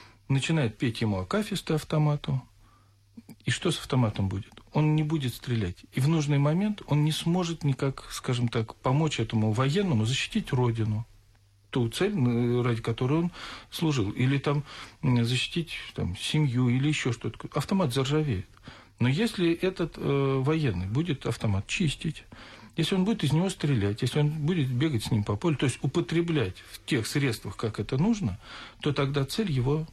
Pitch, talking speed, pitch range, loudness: 135 Hz, 160 wpm, 115-155 Hz, -28 LUFS